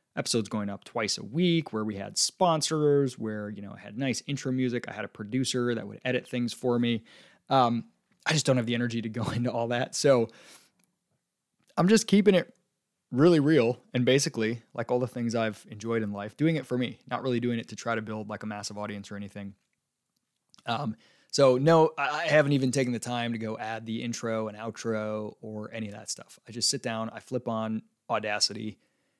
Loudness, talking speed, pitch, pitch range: -28 LUFS, 215 wpm, 120 Hz, 110-135 Hz